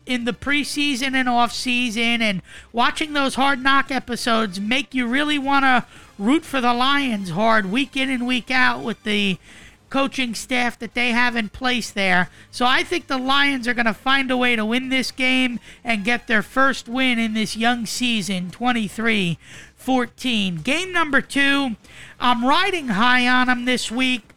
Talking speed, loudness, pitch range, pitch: 175 wpm, -20 LUFS, 225-265 Hz, 250 Hz